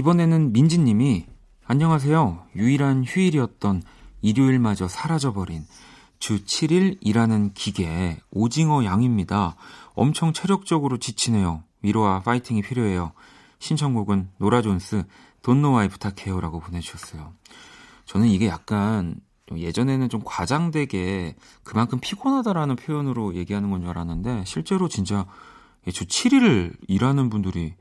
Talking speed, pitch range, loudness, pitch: 310 characters per minute, 95-140 Hz, -22 LUFS, 110 Hz